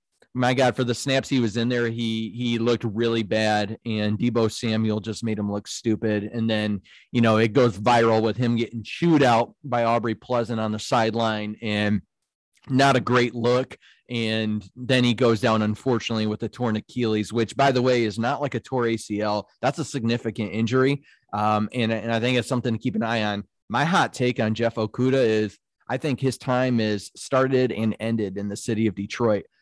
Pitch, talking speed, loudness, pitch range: 115 Hz, 205 wpm, -23 LUFS, 110-125 Hz